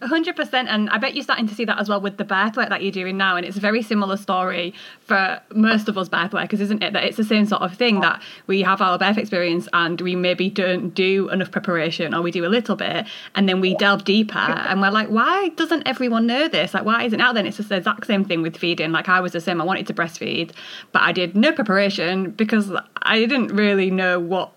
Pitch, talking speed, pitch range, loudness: 195 Hz, 260 wpm, 185-220 Hz, -20 LUFS